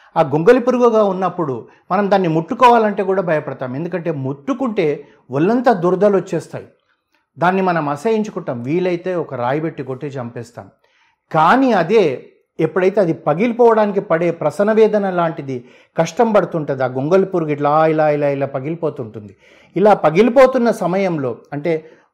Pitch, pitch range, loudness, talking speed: 170 Hz, 145-205 Hz, -16 LUFS, 120 wpm